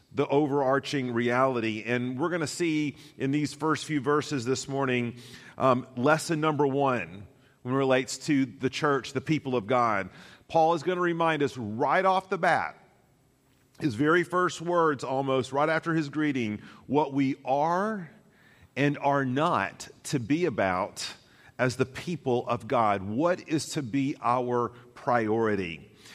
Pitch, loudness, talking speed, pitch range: 140 Hz, -27 LUFS, 155 wpm, 125-155 Hz